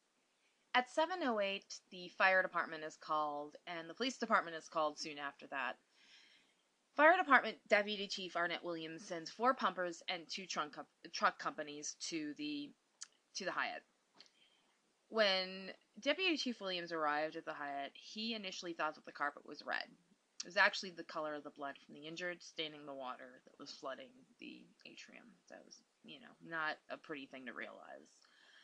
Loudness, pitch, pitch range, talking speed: -39 LUFS, 185 Hz, 155-235 Hz, 170 wpm